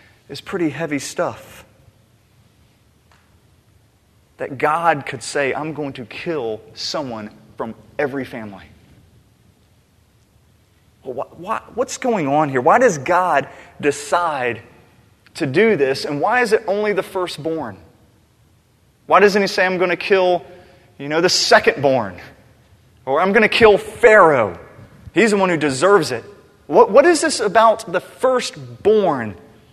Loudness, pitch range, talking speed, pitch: -17 LUFS, 115-185 Hz, 135 wpm, 150 Hz